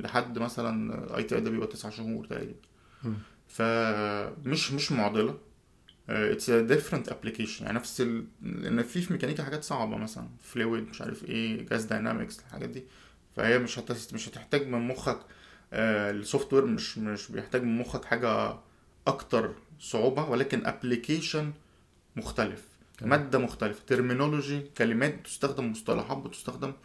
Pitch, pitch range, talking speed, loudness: 120 Hz, 110-145 Hz, 135 wpm, -31 LUFS